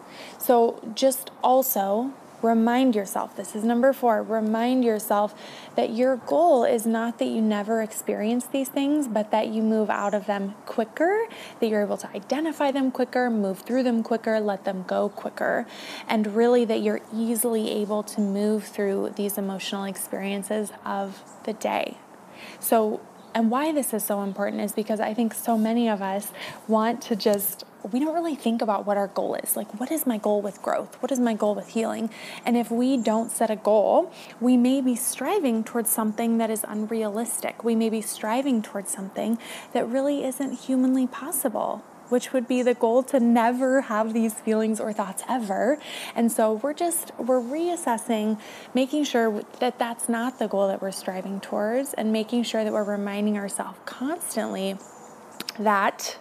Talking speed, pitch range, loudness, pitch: 175 wpm, 210-250 Hz, -25 LUFS, 225 Hz